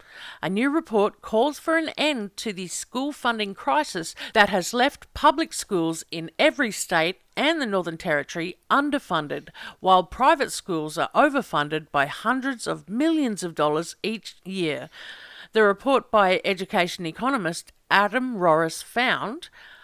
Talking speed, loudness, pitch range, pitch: 140 wpm, -24 LUFS, 170-270 Hz, 205 Hz